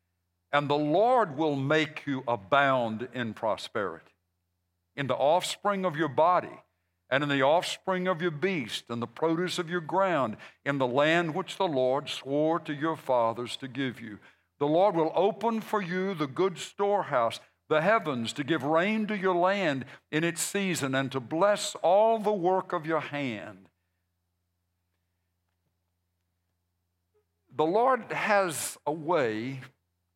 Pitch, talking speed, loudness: 145 Hz, 150 wpm, -28 LUFS